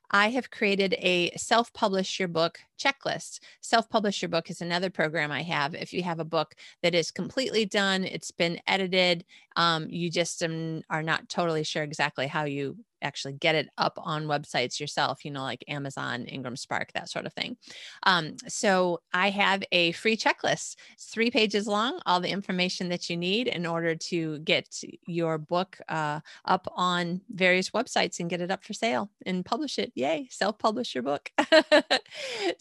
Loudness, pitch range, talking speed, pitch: -27 LUFS, 165-210 Hz, 180 wpm, 180 Hz